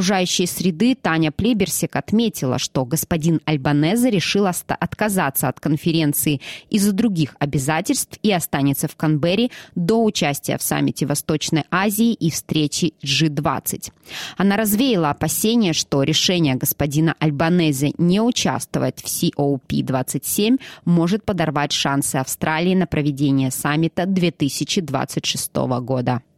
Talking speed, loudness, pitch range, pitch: 115 wpm, -19 LUFS, 145-190 Hz, 160 Hz